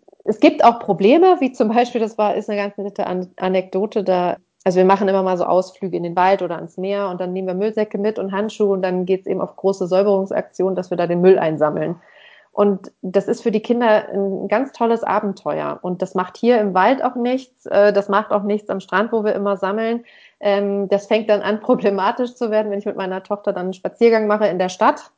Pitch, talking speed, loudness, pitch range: 200 Hz, 230 wpm, -18 LUFS, 185-215 Hz